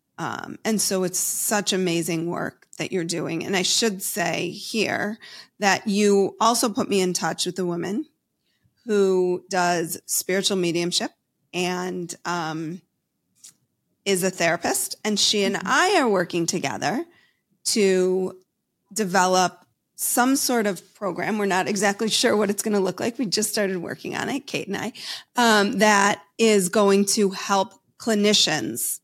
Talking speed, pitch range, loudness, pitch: 150 wpm, 180-210 Hz, -22 LUFS, 195 Hz